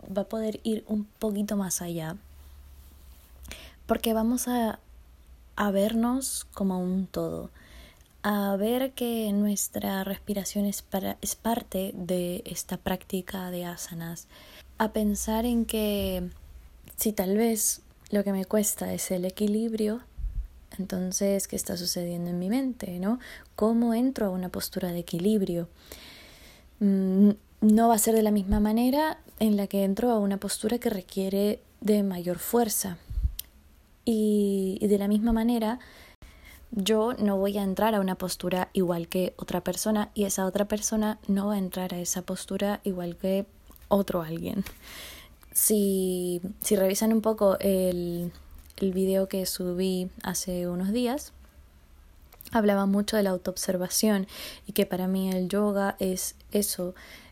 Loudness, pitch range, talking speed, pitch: -28 LUFS, 180-215 Hz, 145 wpm, 195 Hz